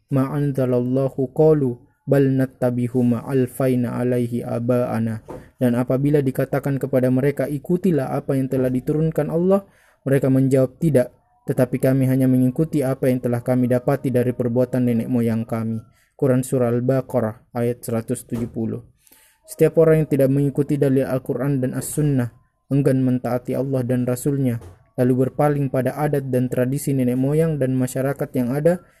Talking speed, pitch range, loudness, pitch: 135 wpm, 125-140 Hz, -20 LUFS, 130 Hz